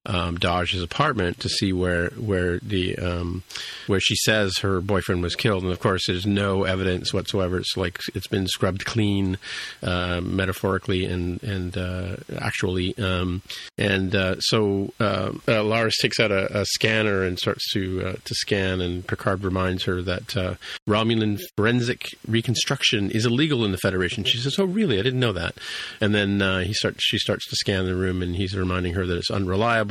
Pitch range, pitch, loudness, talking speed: 90-110 Hz, 95 Hz, -23 LUFS, 185 wpm